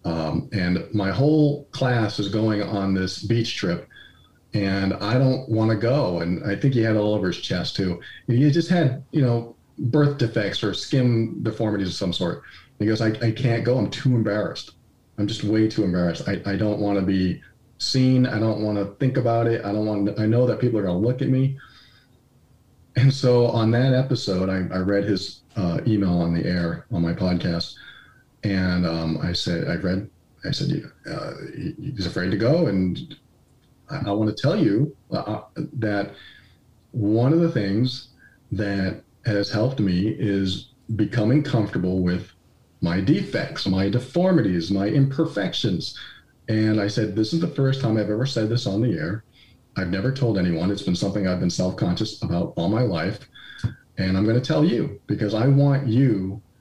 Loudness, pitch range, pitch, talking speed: -23 LUFS, 100-125 Hz, 110 Hz, 195 wpm